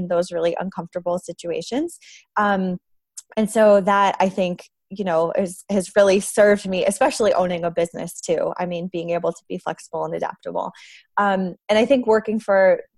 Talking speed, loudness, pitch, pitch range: 175 wpm, -21 LUFS, 195 Hz, 175-215 Hz